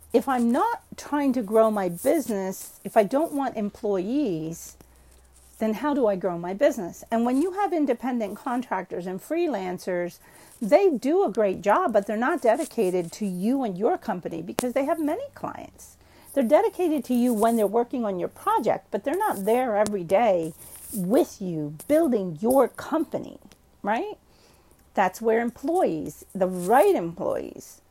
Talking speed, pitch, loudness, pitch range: 160 wpm, 230 Hz, -25 LUFS, 190-285 Hz